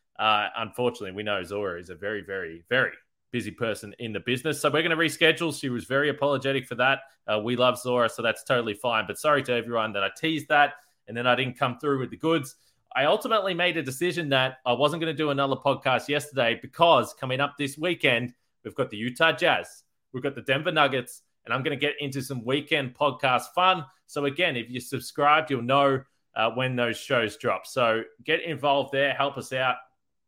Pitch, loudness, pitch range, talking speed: 135 Hz, -25 LUFS, 120-150 Hz, 215 wpm